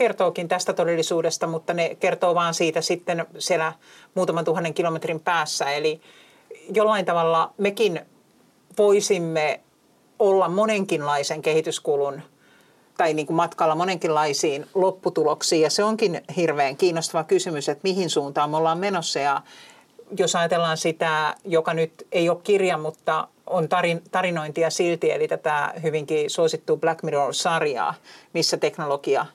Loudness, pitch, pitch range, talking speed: -23 LUFS, 170 Hz, 160-190 Hz, 125 wpm